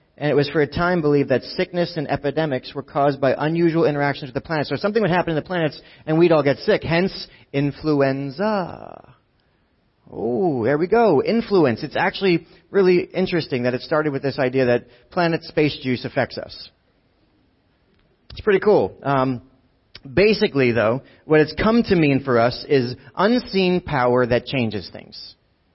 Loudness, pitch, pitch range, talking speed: -20 LUFS, 145 Hz, 130-175 Hz, 170 wpm